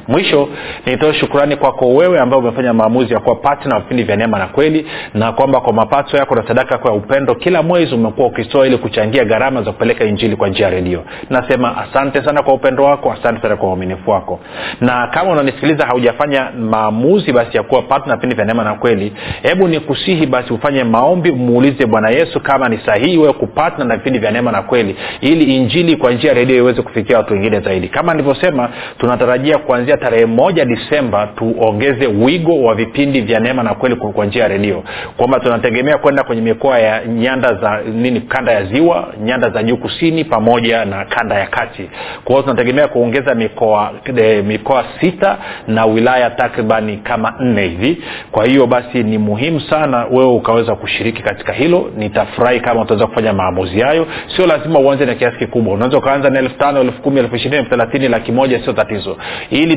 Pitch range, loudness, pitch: 110-140 Hz, -13 LUFS, 125 Hz